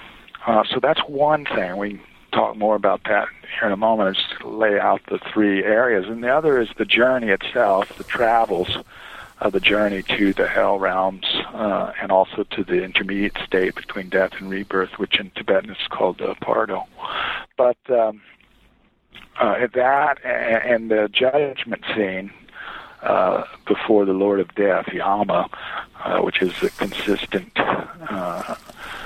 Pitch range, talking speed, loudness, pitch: 95-115 Hz, 160 wpm, -20 LUFS, 105 Hz